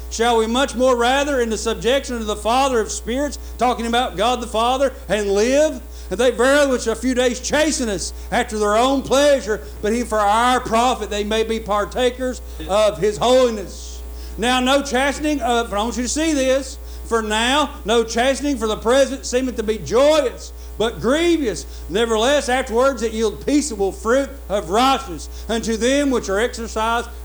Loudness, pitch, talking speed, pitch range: -19 LUFS, 235 Hz, 180 wpm, 215-265 Hz